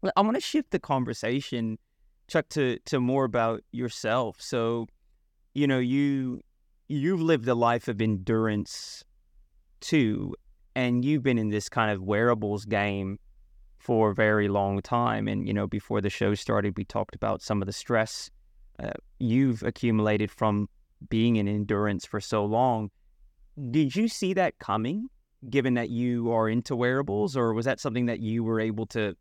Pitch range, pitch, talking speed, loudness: 105-125 Hz, 115 Hz, 165 wpm, -27 LUFS